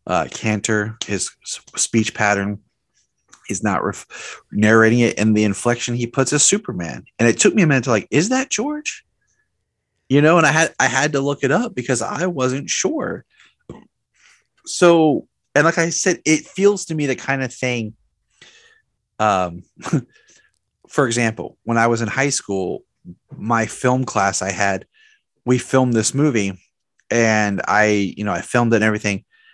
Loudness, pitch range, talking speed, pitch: -18 LUFS, 110-155 Hz, 170 wpm, 125 Hz